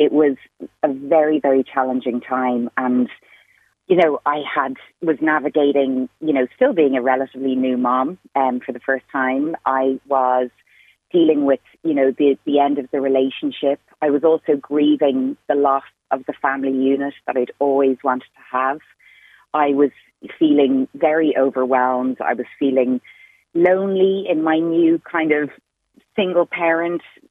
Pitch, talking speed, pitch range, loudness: 140 Hz, 160 wpm, 130-155 Hz, -19 LUFS